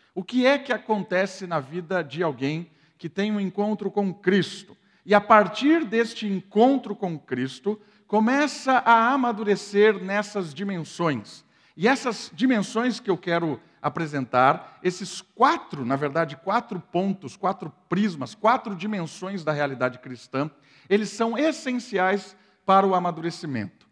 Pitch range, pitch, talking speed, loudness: 165-215 Hz, 195 Hz, 135 wpm, -24 LUFS